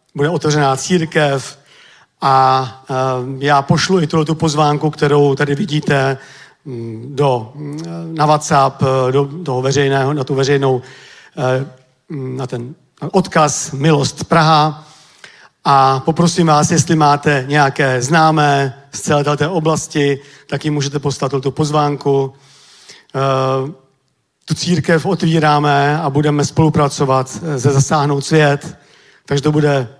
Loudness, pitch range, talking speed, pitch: -15 LUFS, 135-155 Hz, 105 wpm, 145 Hz